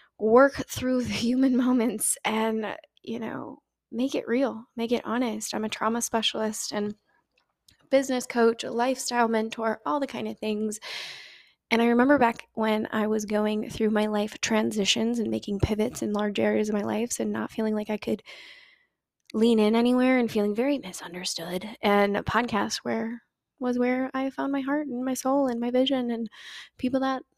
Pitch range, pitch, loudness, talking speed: 215-255 Hz, 230 Hz, -26 LUFS, 180 wpm